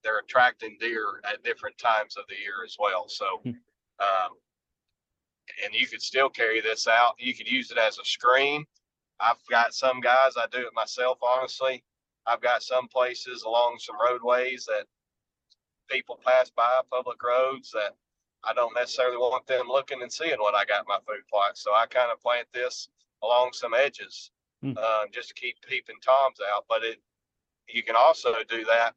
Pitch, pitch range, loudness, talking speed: 125 Hz, 120-130 Hz, -26 LUFS, 180 wpm